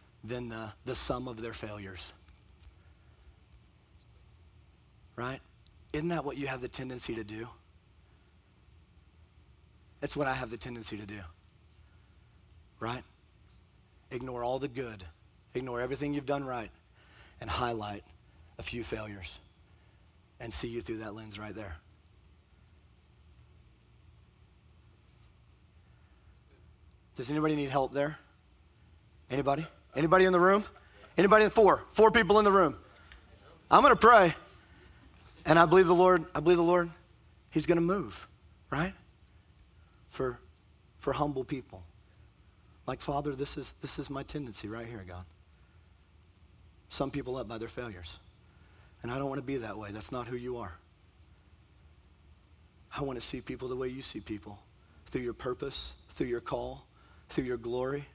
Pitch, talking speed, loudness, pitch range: 105 Hz, 140 wpm, -30 LUFS, 90-130 Hz